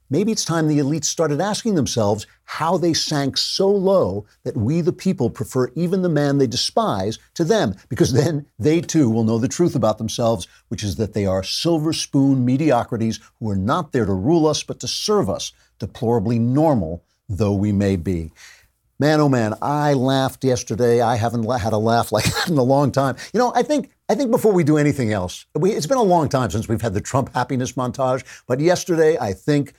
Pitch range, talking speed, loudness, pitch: 115-160 Hz, 210 wpm, -20 LUFS, 130 Hz